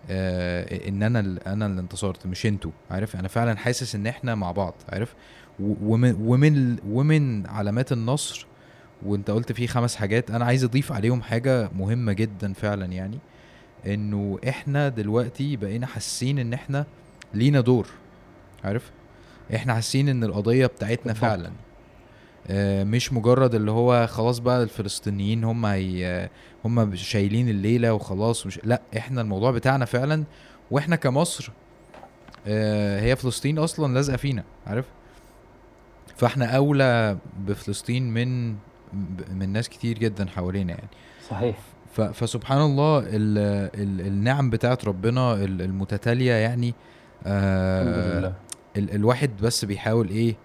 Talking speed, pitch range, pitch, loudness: 125 wpm, 100-125 Hz, 115 Hz, -24 LUFS